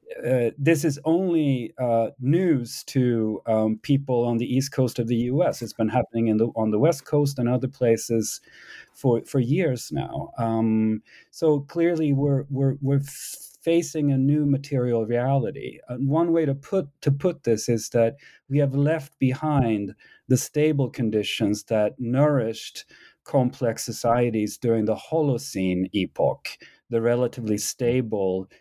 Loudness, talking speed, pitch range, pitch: -24 LUFS, 150 wpm, 115-145 Hz, 125 Hz